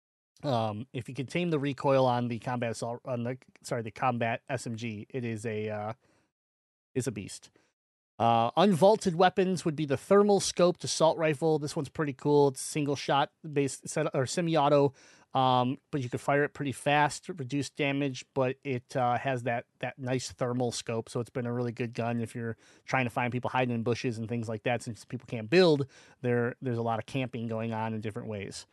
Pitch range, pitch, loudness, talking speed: 115-145 Hz, 130 Hz, -30 LUFS, 210 wpm